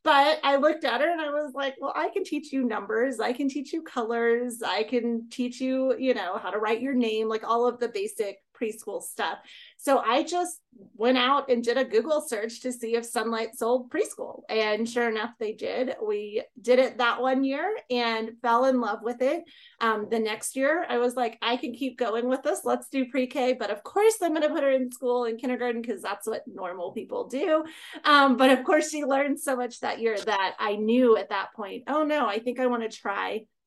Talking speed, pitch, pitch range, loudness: 230 wpm, 250 Hz, 230-290 Hz, -26 LUFS